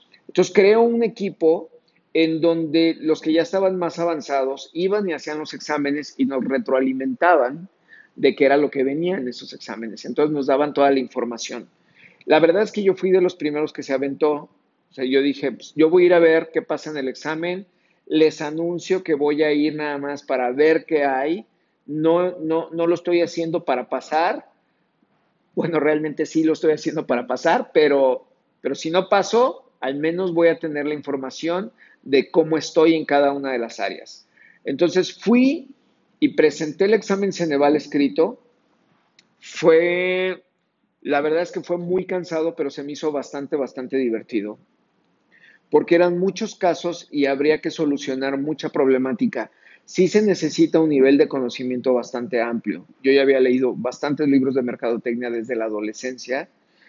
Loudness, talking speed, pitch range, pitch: -20 LUFS, 175 wpm, 135-175 Hz, 155 Hz